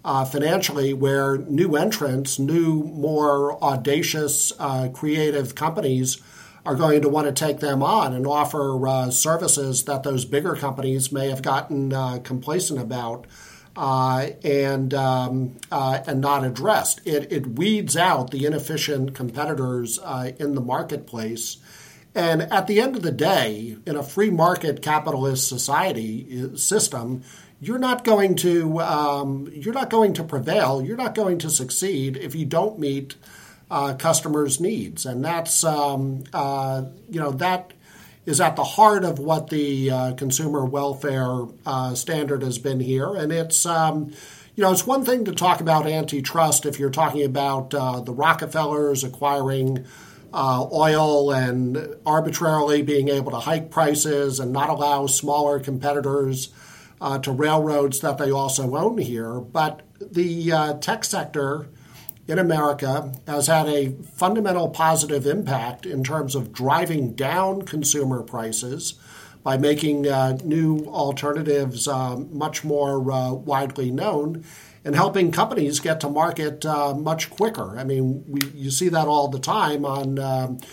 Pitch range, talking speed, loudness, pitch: 135-160 Hz, 150 wpm, -22 LUFS, 145 Hz